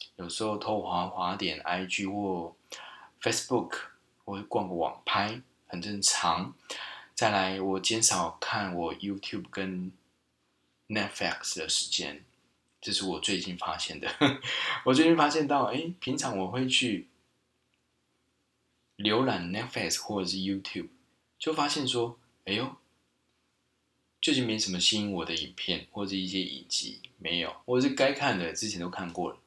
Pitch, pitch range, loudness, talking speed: 95 Hz, 90-115 Hz, -30 LUFS, 260 characters per minute